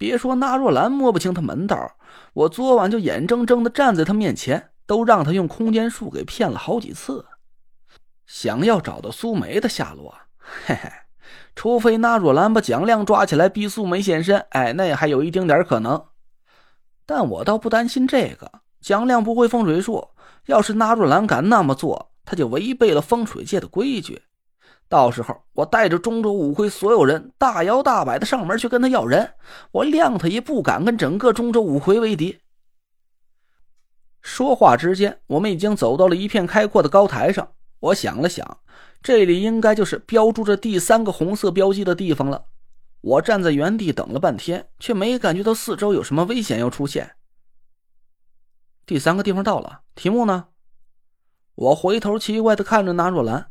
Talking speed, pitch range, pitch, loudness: 265 characters per minute, 170-230 Hz, 210 Hz, -19 LUFS